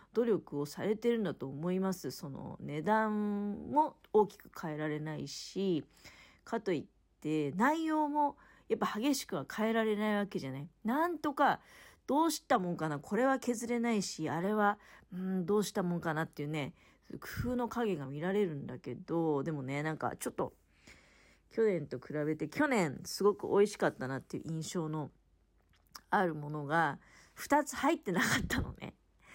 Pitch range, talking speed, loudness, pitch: 155-230 Hz, 325 characters per minute, -34 LUFS, 190 Hz